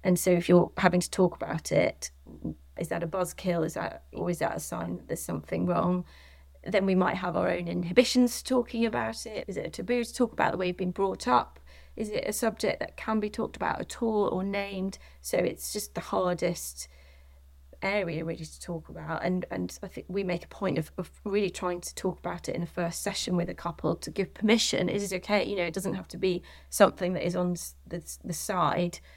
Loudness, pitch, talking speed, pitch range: -29 LUFS, 175 Hz, 235 wpm, 135-195 Hz